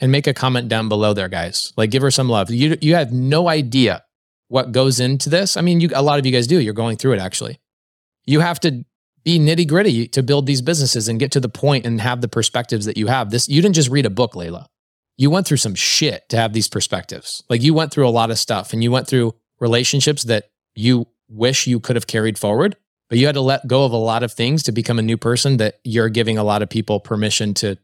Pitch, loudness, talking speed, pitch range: 125 Hz, -17 LUFS, 260 wpm, 115-140 Hz